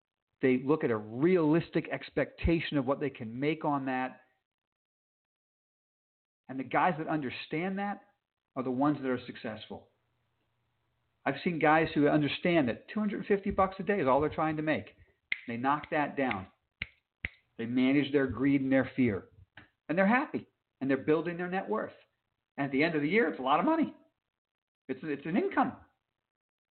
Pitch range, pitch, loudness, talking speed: 130-165 Hz, 145 Hz, -31 LUFS, 175 wpm